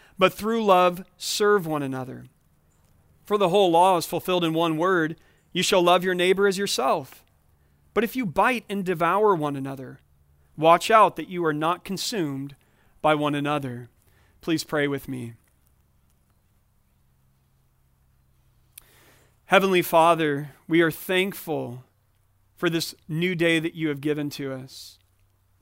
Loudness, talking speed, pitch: -23 LUFS, 140 wpm, 155 Hz